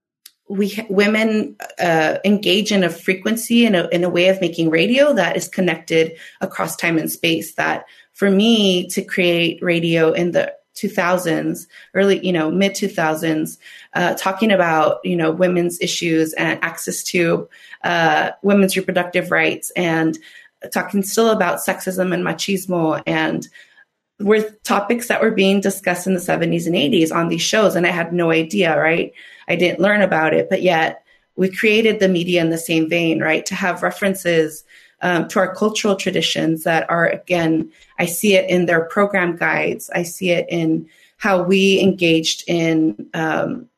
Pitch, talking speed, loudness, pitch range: 180 Hz, 165 wpm, -17 LUFS, 170-195 Hz